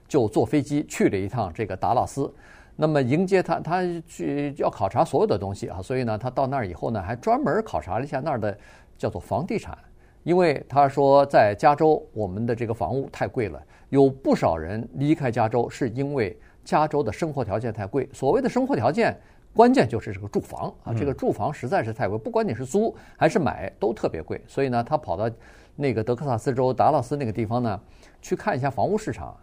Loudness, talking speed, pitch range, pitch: -24 LUFS, 320 characters per minute, 110-150 Hz, 130 Hz